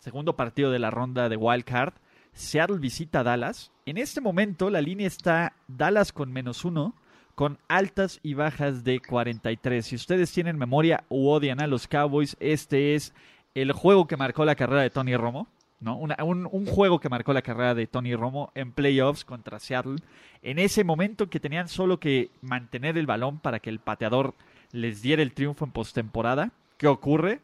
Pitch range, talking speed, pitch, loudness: 125-165 Hz, 190 wpm, 140 Hz, -26 LUFS